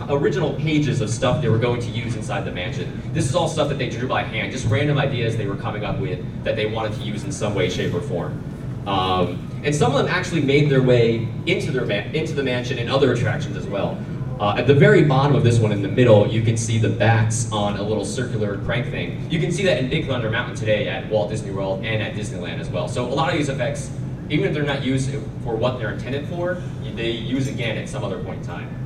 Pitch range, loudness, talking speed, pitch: 115-140 Hz, -21 LUFS, 260 wpm, 130 Hz